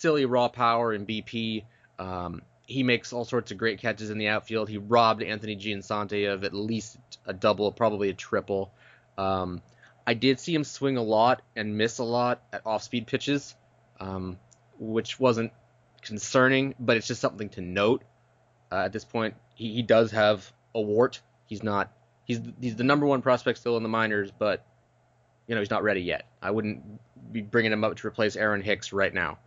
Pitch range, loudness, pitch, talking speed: 105-120 Hz, -27 LUFS, 110 Hz, 190 wpm